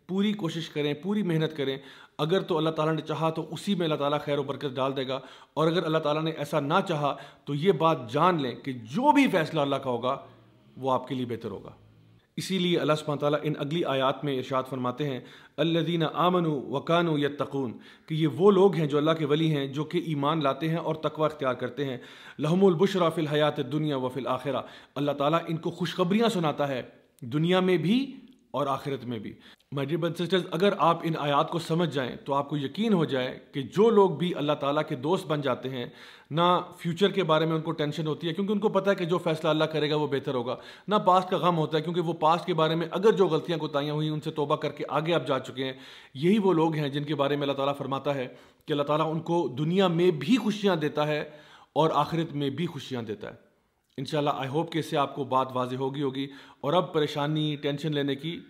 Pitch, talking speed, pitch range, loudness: 155 Hz, 235 wpm, 140-170 Hz, -27 LUFS